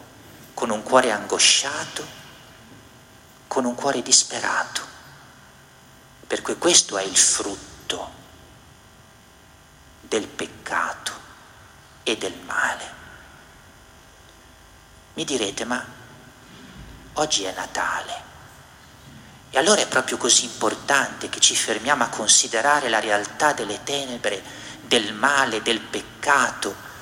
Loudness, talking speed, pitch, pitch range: -21 LUFS, 95 wpm, 110 Hz, 80-130 Hz